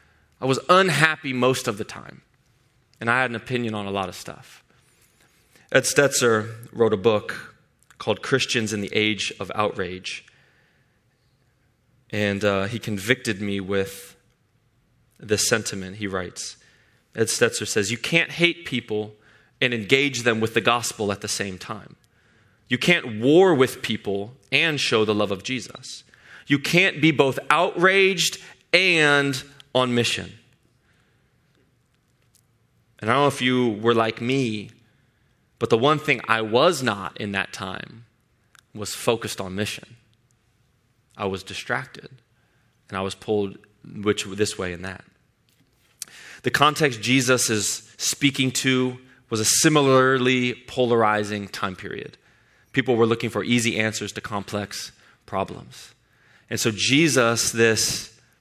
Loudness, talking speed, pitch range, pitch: -22 LUFS, 140 wpm, 105-130 Hz, 120 Hz